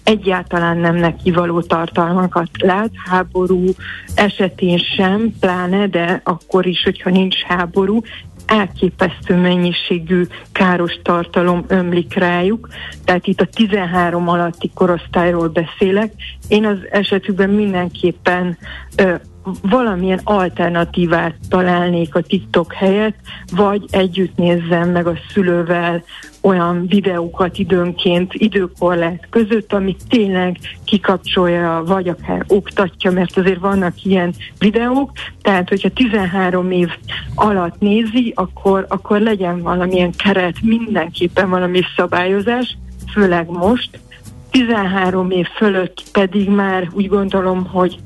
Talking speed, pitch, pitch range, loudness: 105 wpm, 185 Hz, 175-200 Hz, -16 LUFS